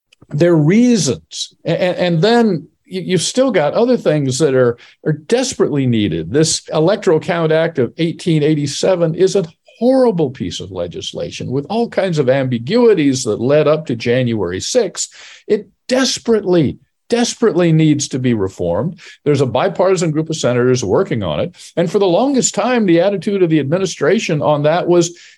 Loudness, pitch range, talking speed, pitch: -15 LUFS, 145-205 Hz, 160 wpm, 170 Hz